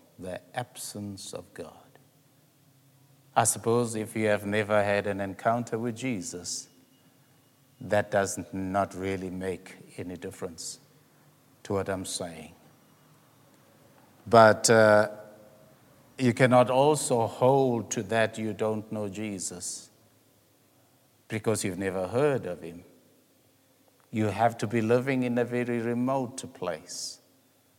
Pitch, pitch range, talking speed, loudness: 115 Hz, 100-130 Hz, 115 wpm, -27 LUFS